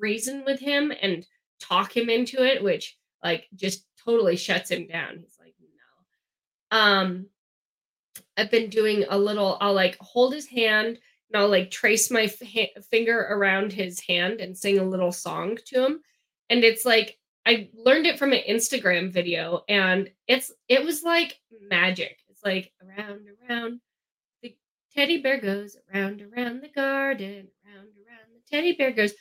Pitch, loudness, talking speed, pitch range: 215 Hz, -24 LUFS, 165 wpm, 195-245 Hz